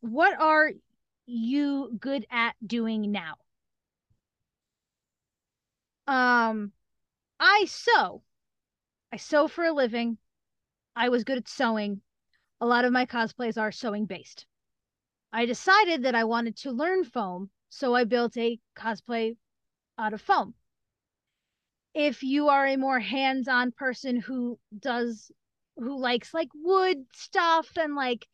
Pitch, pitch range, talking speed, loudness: 250 Hz, 230-285 Hz, 130 wpm, -26 LUFS